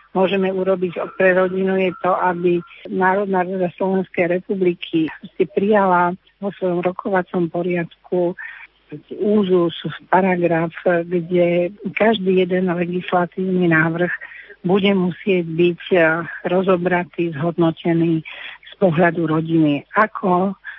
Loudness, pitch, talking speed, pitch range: -19 LUFS, 180 Hz, 95 wpm, 175-190 Hz